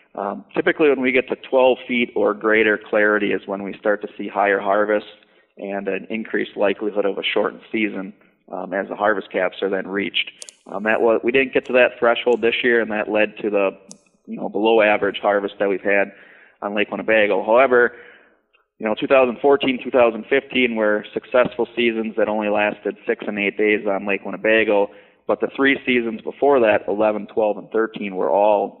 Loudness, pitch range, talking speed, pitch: -19 LUFS, 100-120 Hz, 190 wpm, 105 Hz